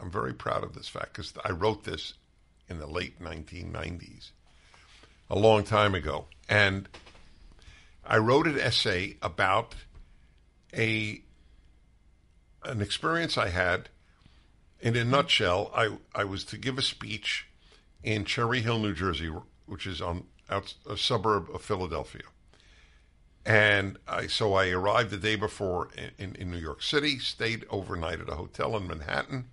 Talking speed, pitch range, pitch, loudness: 150 wpm, 80-110 Hz, 95 Hz, -29 LUFS